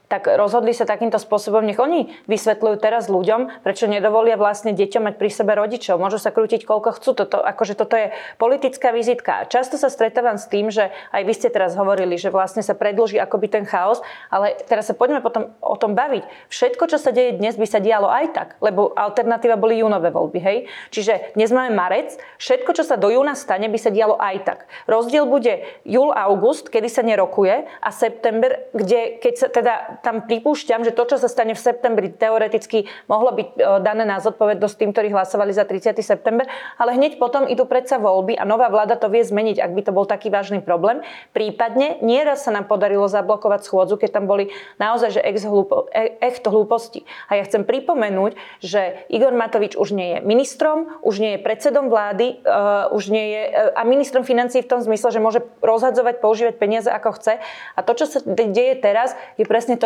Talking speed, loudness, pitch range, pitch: 195 wpm, -19 LUFS, 210-245 Hz, 225 Hz